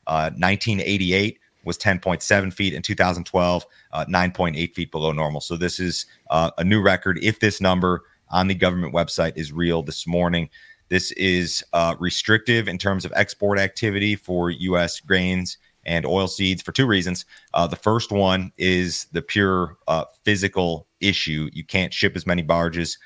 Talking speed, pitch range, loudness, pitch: 175 wpm, 85-100 Hz, -22 LUFS, 90 Hz